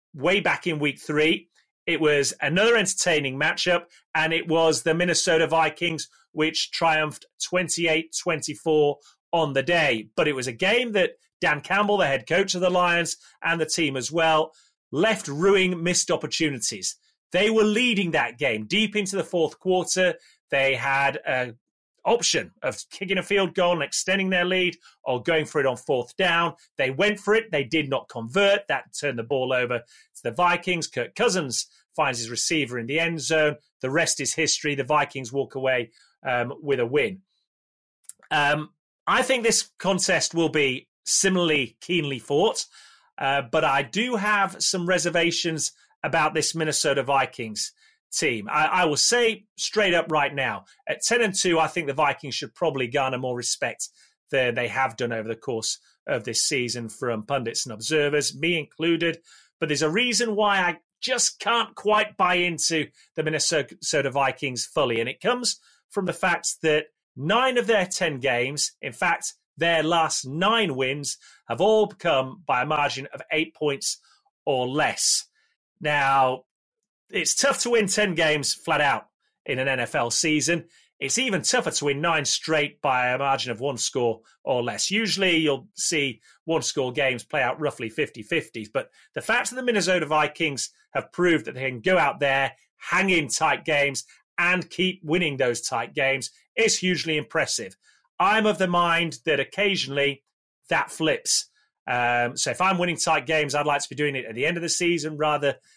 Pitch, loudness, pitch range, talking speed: 160 Hz, -23 LUFS, 140-185 Hz, 175 wpm